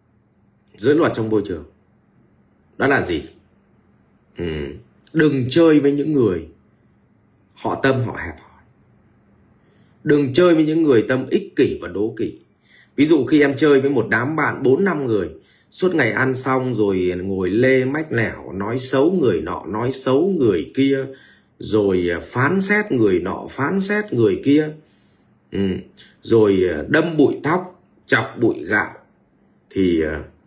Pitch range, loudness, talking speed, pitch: 100-150 Hz, -18 LUFS, 150 wpm, 130 Hz